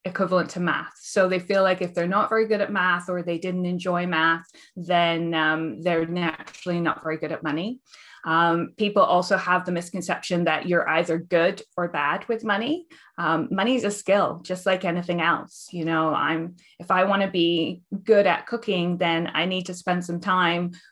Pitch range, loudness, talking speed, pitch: 170-195 Hz, -24 LUFS, 200 wpm, 180 Hz